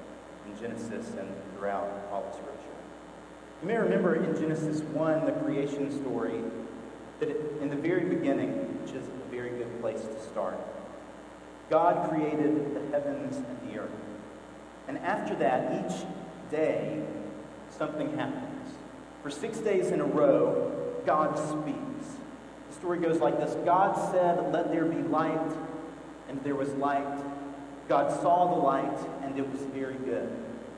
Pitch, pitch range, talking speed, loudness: 155 Hz, 140-200 Hz, 145 wpm, -30 LUFS